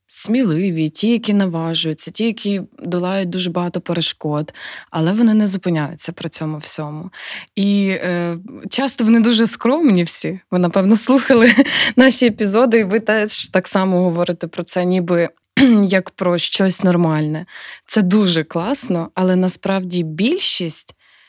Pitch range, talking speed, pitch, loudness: 170-220 Hz, 135 wpm, 185 Hz, -16 LUFS